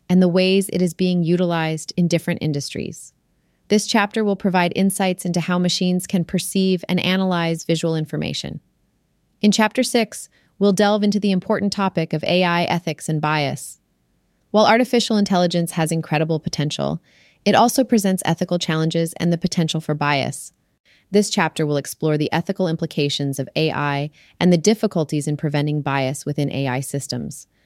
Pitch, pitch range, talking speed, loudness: 175 Hz, 155-195 Hz, 155 wpm, -20 LUFS